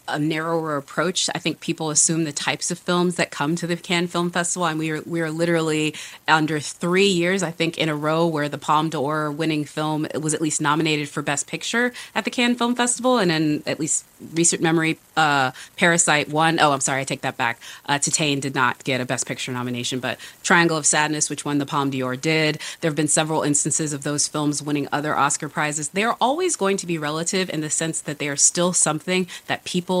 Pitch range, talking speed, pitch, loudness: 150-170 Hz, 230 wpm, 155 Hz, -21 LUFS